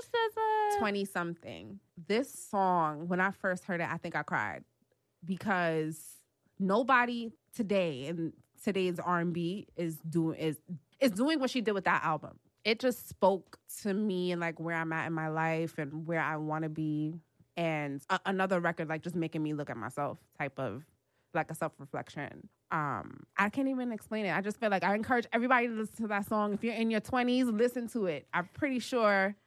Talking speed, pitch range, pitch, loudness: 200 wpm, 160-215 Hz, 175 Hz, -33 LUFS